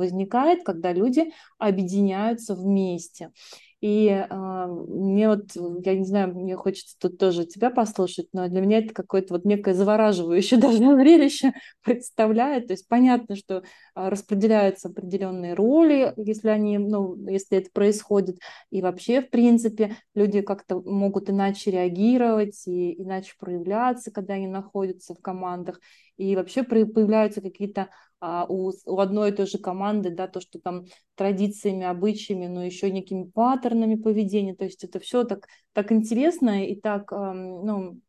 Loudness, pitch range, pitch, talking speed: -23 LUFS, 185-220 Hz, 200 Hz, 140 wpm